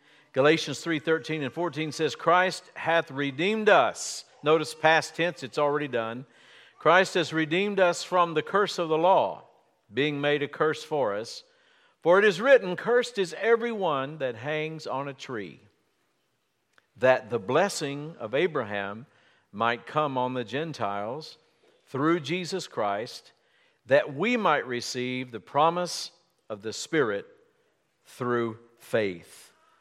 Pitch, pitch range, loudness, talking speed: 155 Hz, 135-180 Hz, -26 LUFS, 135 wpm